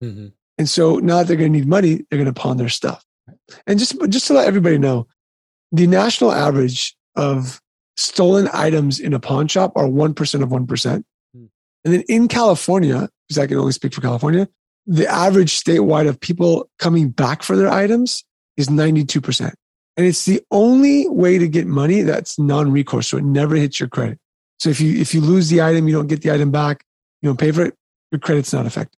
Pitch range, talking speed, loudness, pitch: 140-180 Hz, 205 wpm, -16 LUFS, 155 Hz